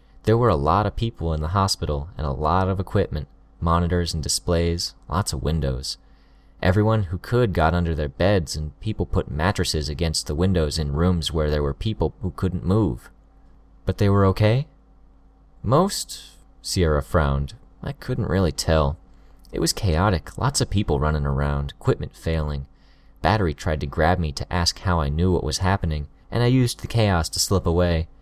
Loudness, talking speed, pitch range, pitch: -23 LUFS, 180 wpm, 75-95 Hz, 85 Hz